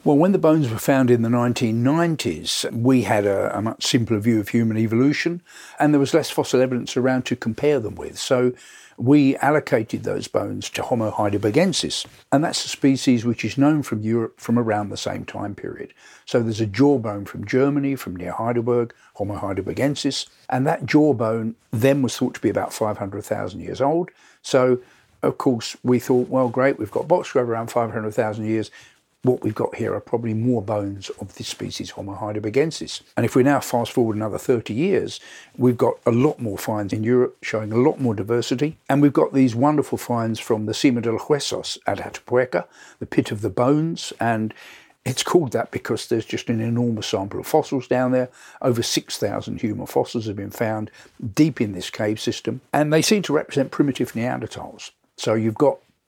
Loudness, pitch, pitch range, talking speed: -21 LUFS, 120 Hz, 110-135 Hz, 190 wpm